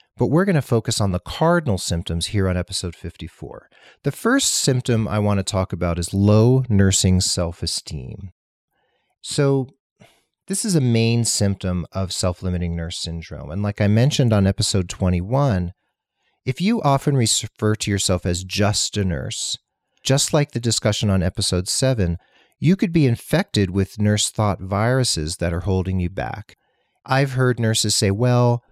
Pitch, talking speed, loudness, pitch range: 105 Hz, 165 wpm, -20 LUFS, 90-125 Hz